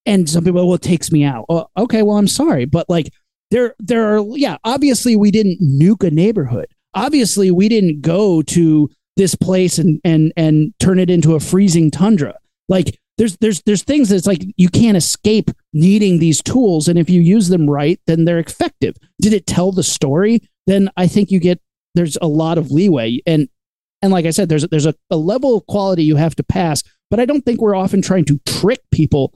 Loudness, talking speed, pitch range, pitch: -14 LUFS, 215 wpm, 160-205 Hz, 180 Hz